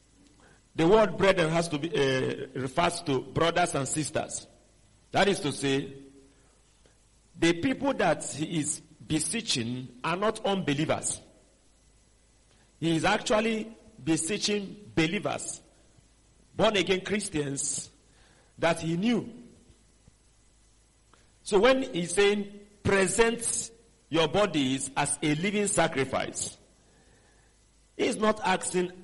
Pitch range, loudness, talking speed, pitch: 140-200 Hz, -28 LUFS, 105 wpm, 165 Hz